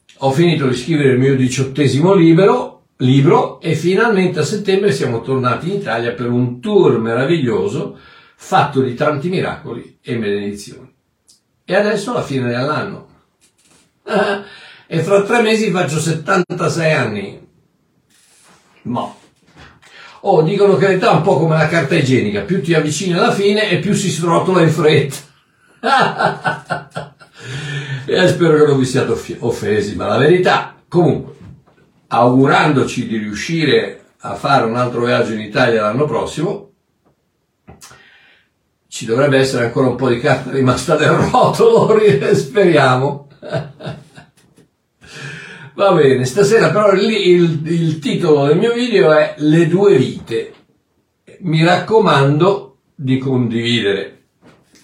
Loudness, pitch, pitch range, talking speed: -14 LUFS, 155 Hz, 130-185 Hz, 125 wpm